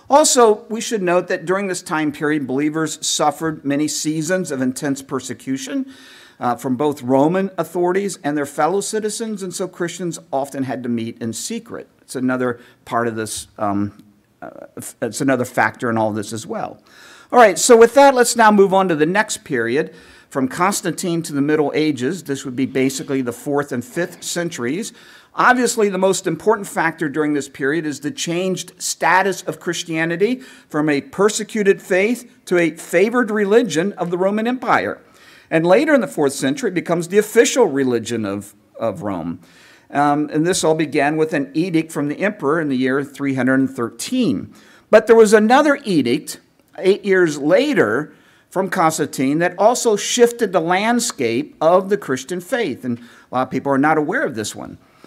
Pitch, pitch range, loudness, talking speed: 165 Hz, 135-200 Hz, -18 LUFS, 180 wpm